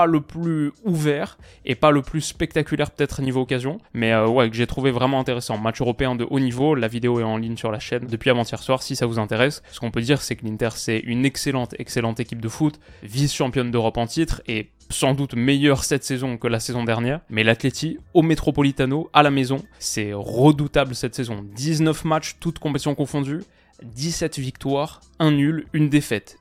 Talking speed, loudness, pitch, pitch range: 210 wpm, -22 LUFS, 135 Hz, 120-150 Hz